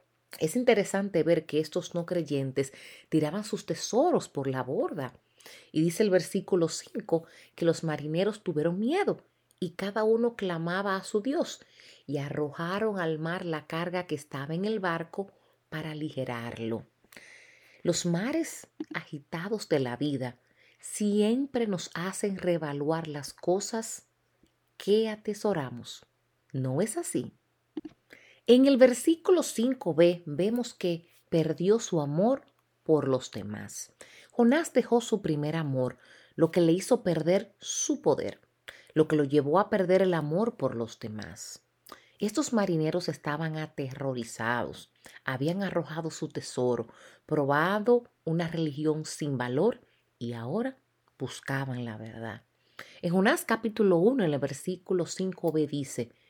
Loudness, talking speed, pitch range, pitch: -29 LUFS, 130 wpm, 145-205 Hz, 170 Hz